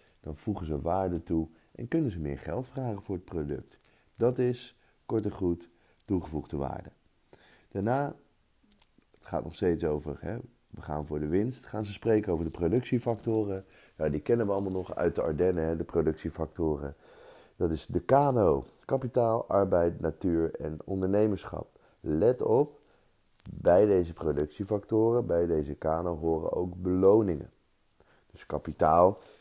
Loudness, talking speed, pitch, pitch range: -29 LUFS, 150 wpm, 95 Hz, 80-110 Hz